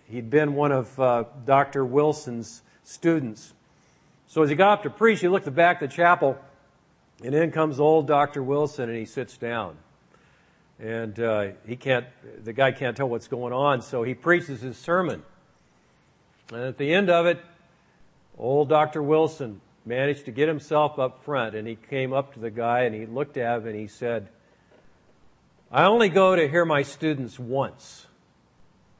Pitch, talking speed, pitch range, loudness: 135 Hz, 180 wpm, 120-150 Hz, -24 LUFS